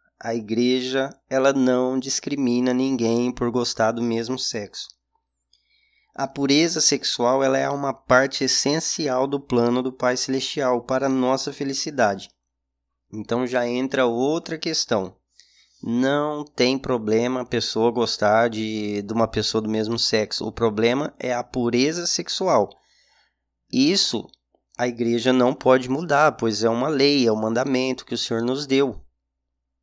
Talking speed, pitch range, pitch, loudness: 140 wpm, 115-135 Hz, 125 Hz, -22 LUFS